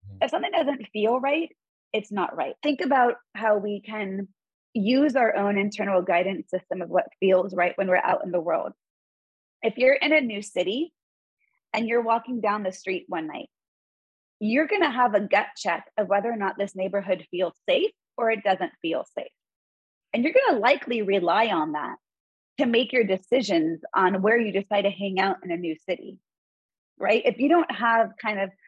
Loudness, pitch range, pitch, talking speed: -24 LUFS, 190-260 Hz, 215 Hz, 195 wpm